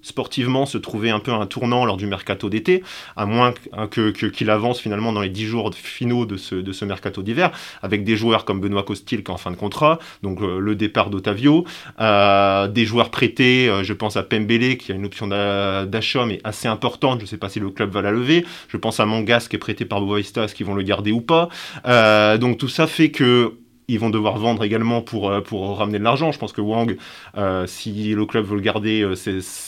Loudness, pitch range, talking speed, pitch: -20 LUFS, 100-120 Hz, 240 wpm, 110 Hz